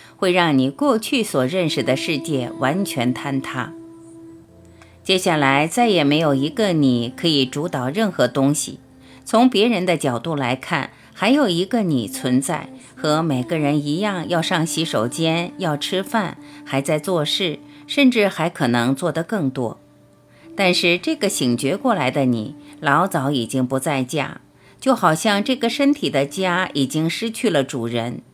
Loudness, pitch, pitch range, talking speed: -20 LUFS, 155 Hz, 135-185 Hz, 230 characters per minute